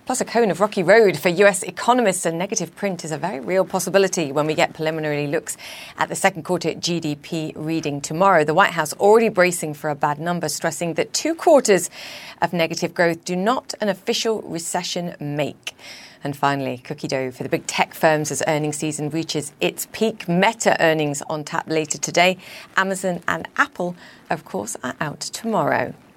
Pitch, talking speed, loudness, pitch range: 170 Hz, 180 wpm, -21 LUFS, 155-195 Hz